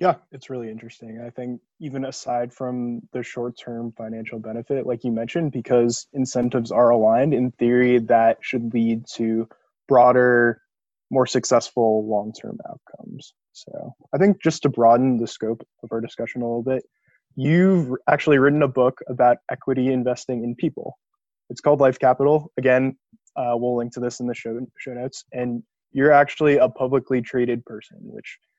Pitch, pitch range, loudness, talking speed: 125 Hz, 120-135 Hz, -21 LUFS, 170 wpm